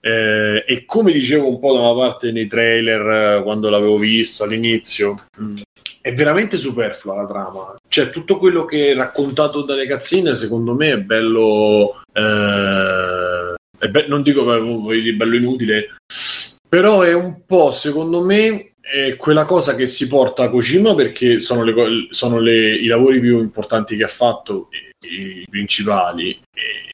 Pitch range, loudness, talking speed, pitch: 110-145 Hz, -15 LUFS, 165 wpm, 120 Hz